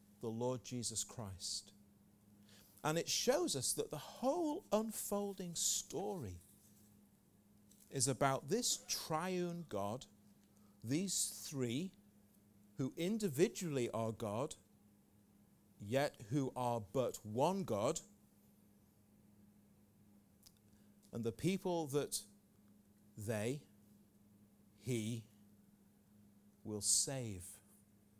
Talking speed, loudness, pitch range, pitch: 80 wpm, -40 LUFS, 100-135 Hz, 105 Hz